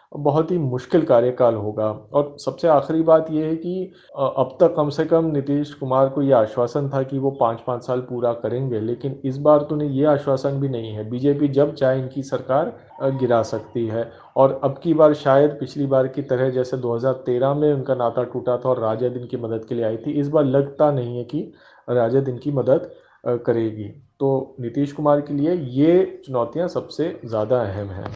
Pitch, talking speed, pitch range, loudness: 135 Hz, 200 wpm, 120-145 Hz, -21 LUFS